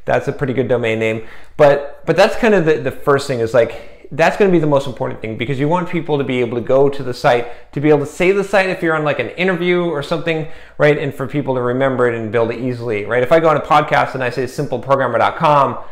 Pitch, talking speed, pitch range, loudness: 140 Hz, 275 wpm, 125-160 Hz, -16 LUFS